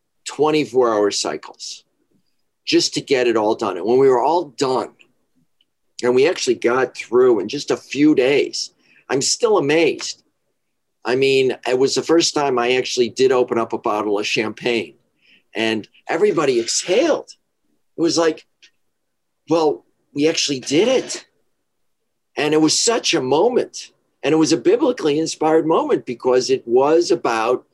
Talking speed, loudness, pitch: 155 wpm, -18 LUFS, 165 Hz